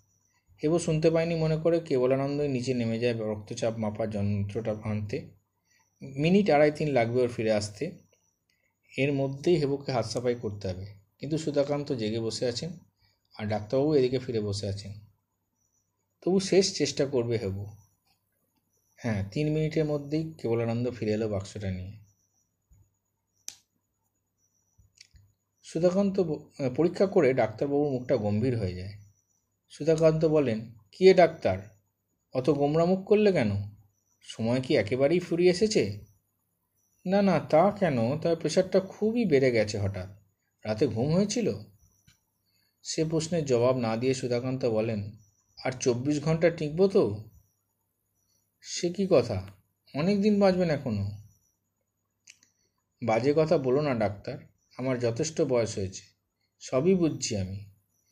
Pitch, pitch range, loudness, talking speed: 115 Hz, 100-150 Hz, -27 LUFS, 120 wpm